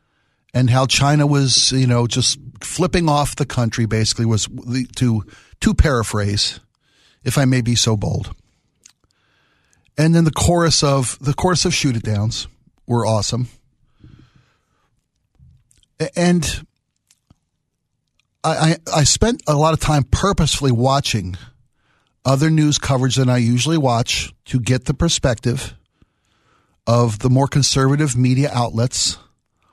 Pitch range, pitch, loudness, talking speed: 120-145 Hz, 130 Hz, -17 LUFS, 120 wpm